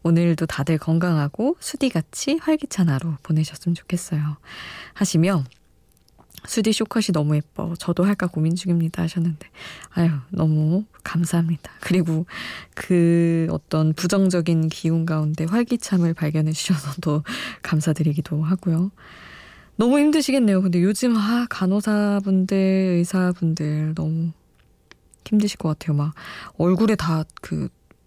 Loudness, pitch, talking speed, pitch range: -22 LUFS, 170 Hz, 285 characters per minute, 155-190 Hz